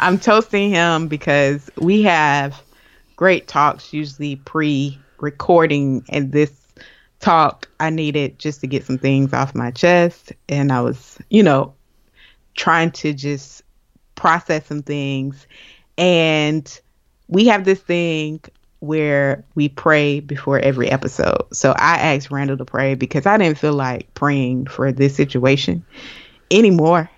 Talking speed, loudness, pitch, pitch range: 135 wpm, -17 LUFS, 145 Hz, 135-165 Hz